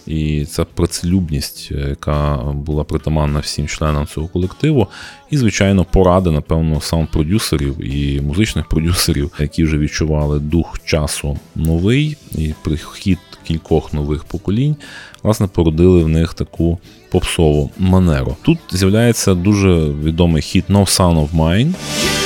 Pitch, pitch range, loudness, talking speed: 80 Hz, 75-95 Hz, -16 LUFS, 125 wpm